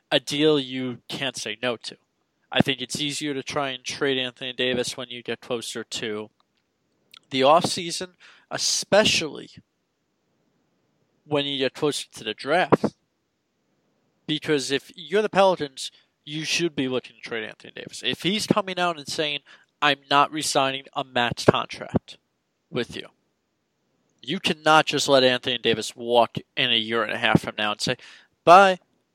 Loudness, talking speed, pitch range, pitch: -23 LUFS, 160 wpm, 125-155 Hz, 140 Hz